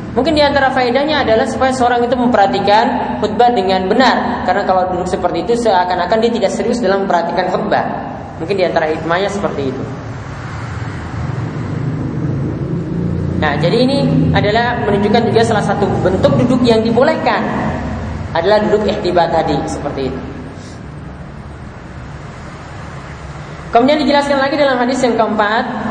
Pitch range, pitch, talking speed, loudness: 165-240 Hz, 205 Hz, 125 wpm, -14 LUFS